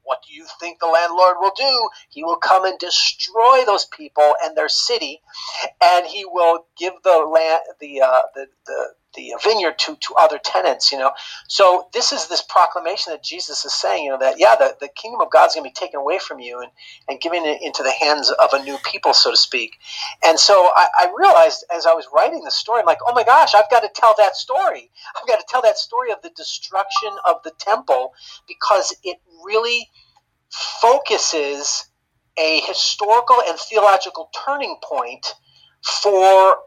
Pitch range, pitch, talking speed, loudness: 160-235 Hz, 180 Hz, 200 wpm, -16 LUFS